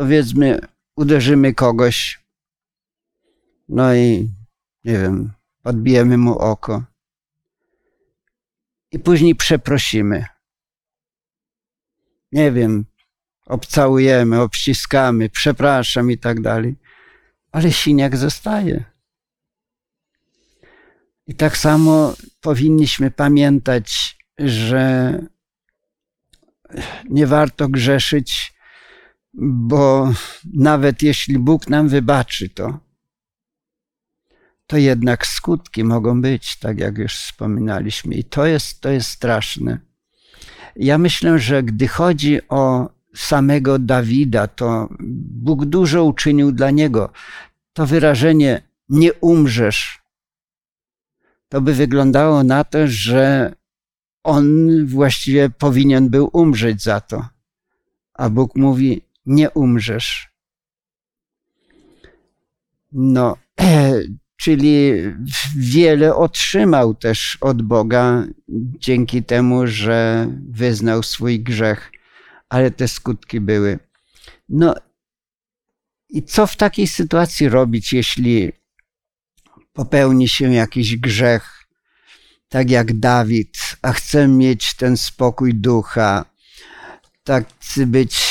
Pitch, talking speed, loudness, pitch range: 135 Hz, 90 wpm, -16 LUFS, 120-150 Hz